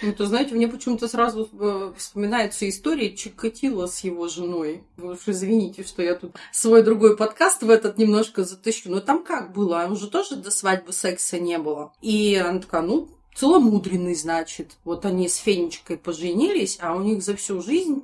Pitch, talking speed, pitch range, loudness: 205 Hz, 175 wpm, 180-225 Hz, -22 LUFS